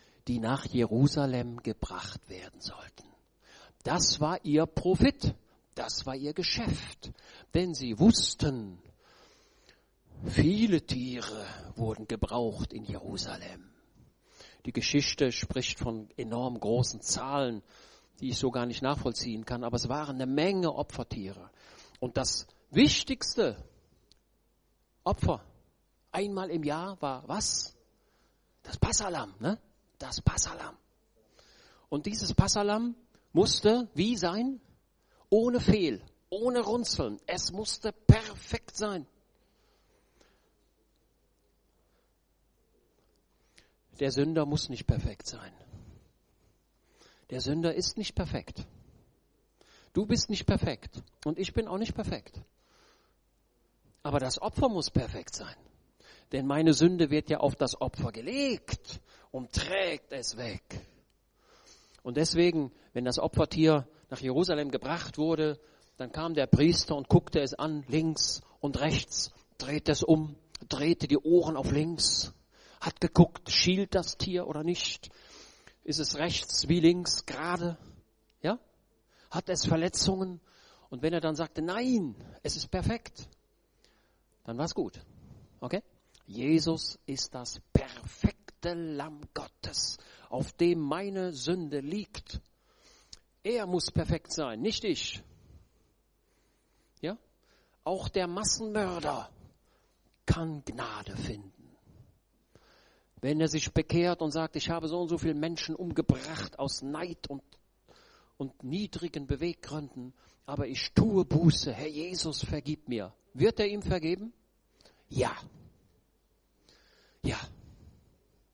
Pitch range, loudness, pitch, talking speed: 130-175 Hz, -31 LUFS, 155 Hz, 115 wpm